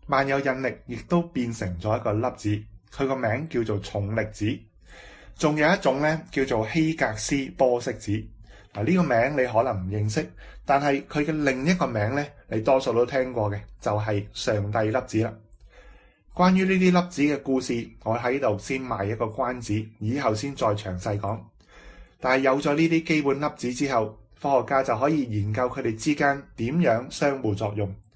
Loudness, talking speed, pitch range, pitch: -25 LUFS, 265 characters per minute, 105-140 Hz, 125 Hz